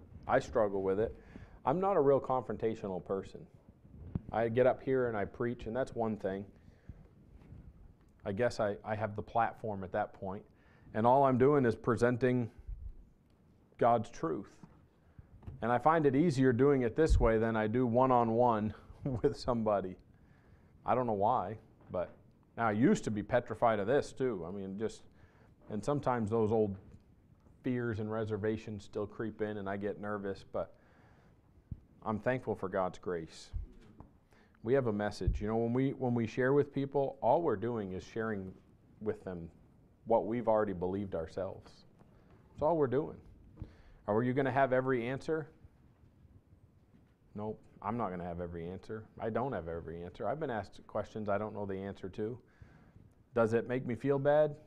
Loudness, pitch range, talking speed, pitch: -34 LUFS, 100-125 Hz, 170 wpm, 110 Hz